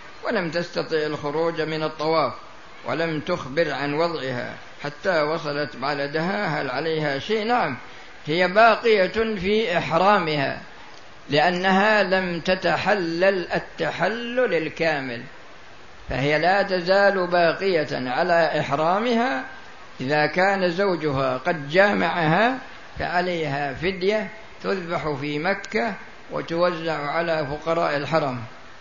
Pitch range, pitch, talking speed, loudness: 150-195 Hz, 165 Hz, 95 wpm, -22 LUFS